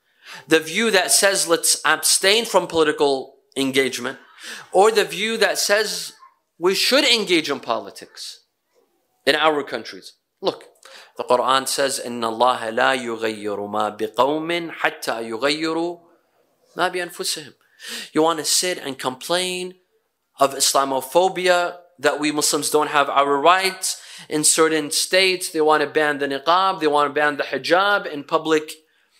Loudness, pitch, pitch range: -19 LUFS, 155 Hz, 135-180 Hz